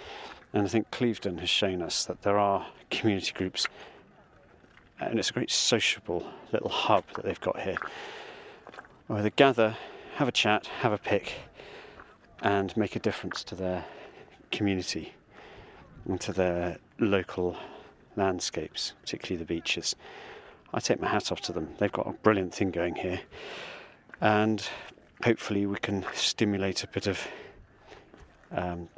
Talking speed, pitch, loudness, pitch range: 145 wpm, 100 Hz, -29 LUFS, 90-105 Hz